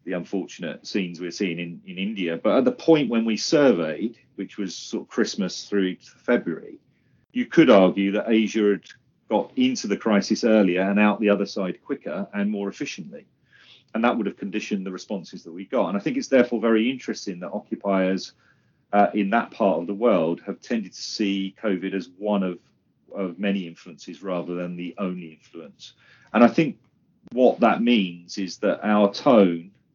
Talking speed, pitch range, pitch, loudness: 190 wpm, 95-110 Hz, 100 Hz, -23 LUFS